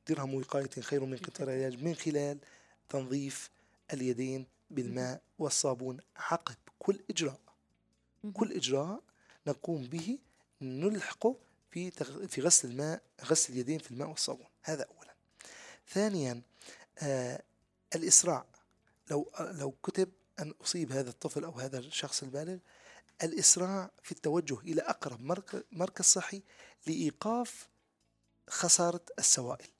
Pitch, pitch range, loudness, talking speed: 150 Hz, 130-180 Hz, -33 LUFS, 110 wpm